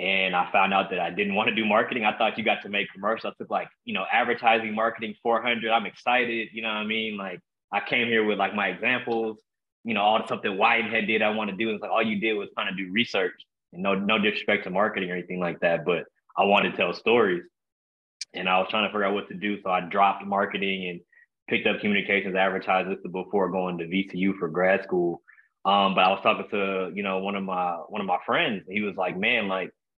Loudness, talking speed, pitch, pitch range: -25 LUFS, 250 wpm, 100 Hz, 95-110 Hz